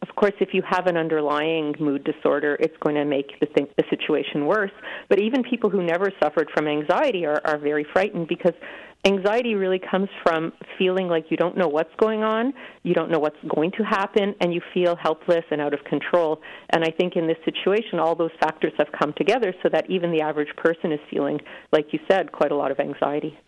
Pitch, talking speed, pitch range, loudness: 170 Hz, 215 wpm, 155-190 Hz, -23 LUFS